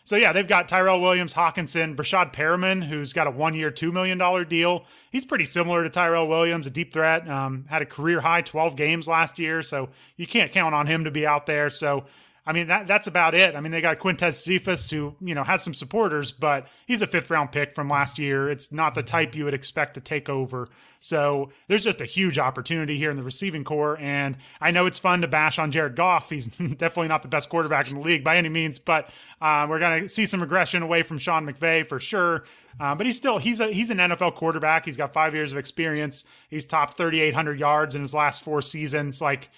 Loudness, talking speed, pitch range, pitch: -23 LUFS, 230 wpm, 145-175 Hz, 160 Hz